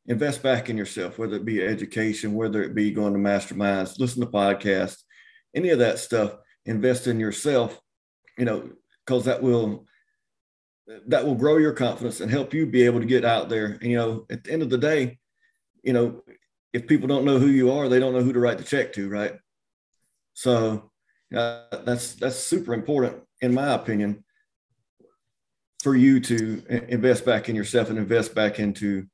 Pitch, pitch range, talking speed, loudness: 120 Hz, 110-130 Hz, 185 wpm, -24 LUFS